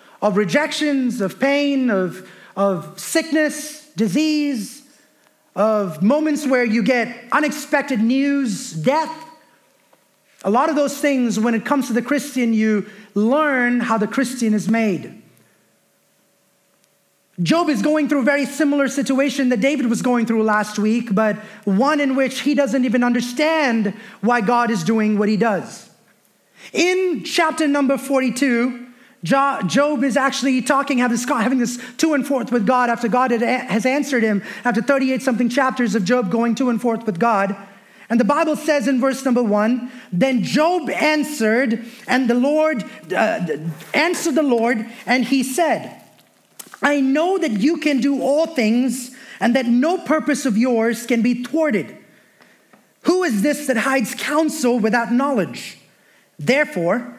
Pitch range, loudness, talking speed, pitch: 230-285 Hz, -19 LUFS, 150 wpm, 255 Hz